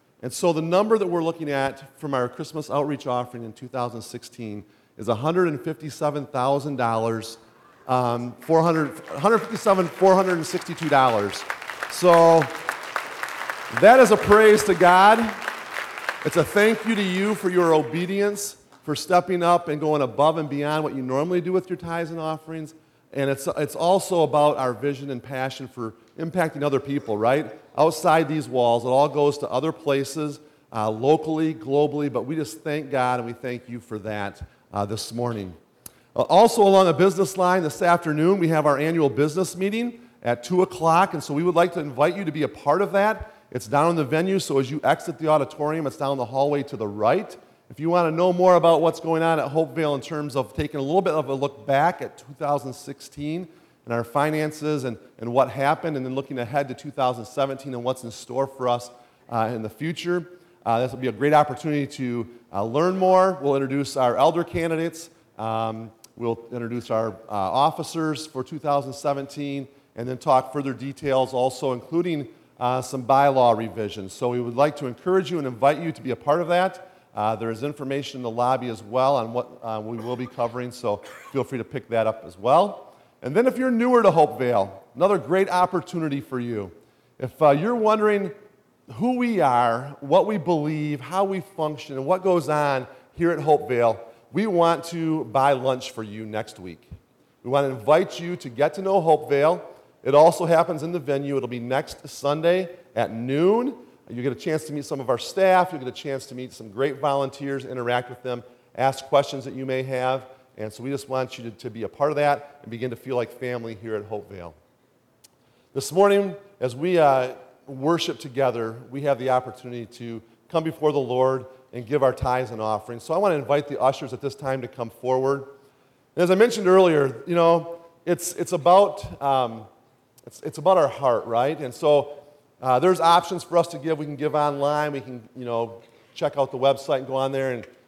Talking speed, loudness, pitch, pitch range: 200 wpm, -23 LUFS, 140 Hz, 125-165 Hz